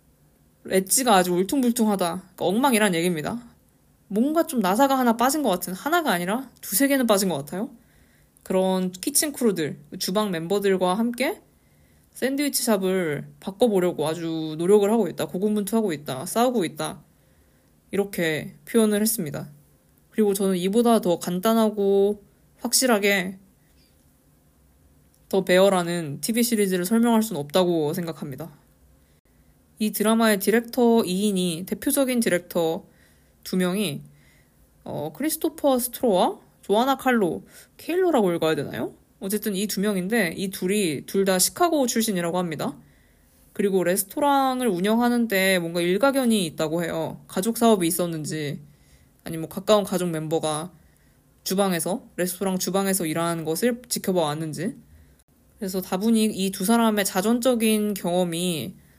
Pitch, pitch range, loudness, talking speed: 195 Hz, 175-230 Hz, -23 LUFS, 310 characters per minute